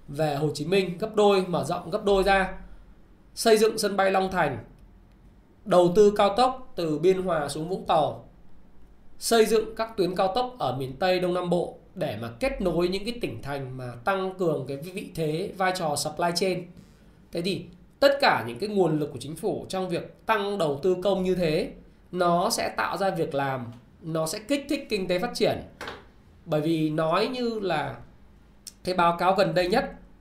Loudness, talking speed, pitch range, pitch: -26 LUFS, 200 wpm, 160-200 Hz, 180 Hz